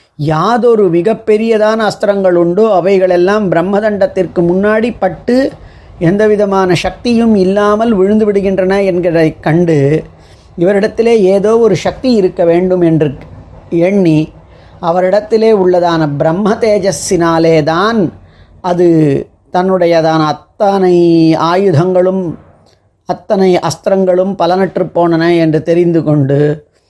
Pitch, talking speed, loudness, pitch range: 180 Hz, 85 wpm, -10 LUFS, 165-200 Hz